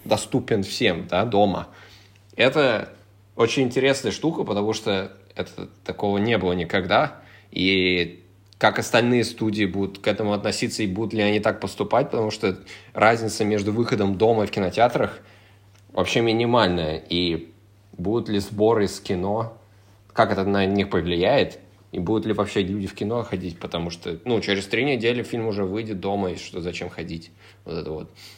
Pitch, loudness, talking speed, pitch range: 100 Hz, -23 LUFS, 160 wpm, 95-110 Hz